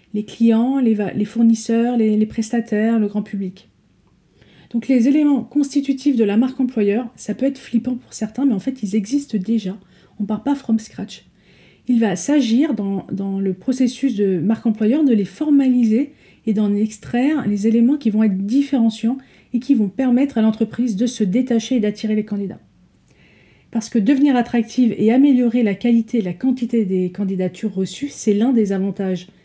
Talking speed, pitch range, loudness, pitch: 185 wpm, 210-255 Hz, -18 LUFS, 230 Hz